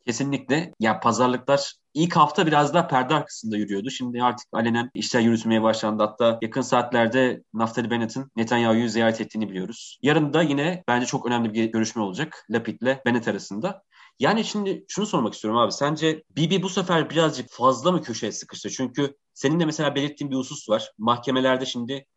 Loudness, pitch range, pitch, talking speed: -23 LUFS, 115-145 Hz, 125 Hz, 175 wpm